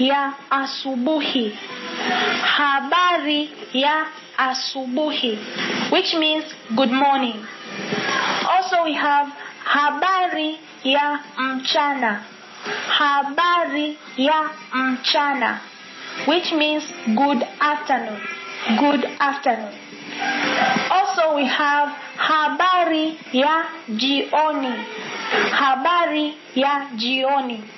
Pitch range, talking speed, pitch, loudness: 265-310 Hz, 70 wpm, 290 Hz, -20 LUFS